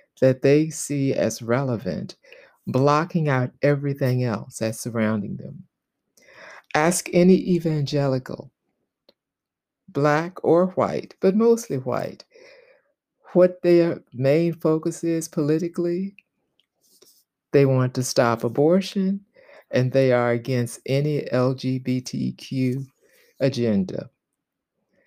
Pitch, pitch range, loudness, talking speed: 145 Hz, 130-175 Hz, -22 LUFS, 95 wpm